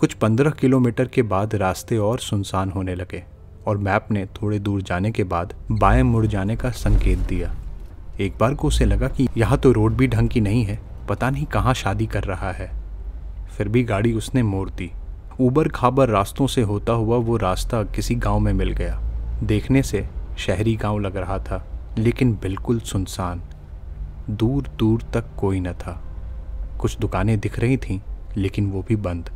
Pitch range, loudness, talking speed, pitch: 90-115 Hz, -22 LUFS, 180 wpm, 105 Hz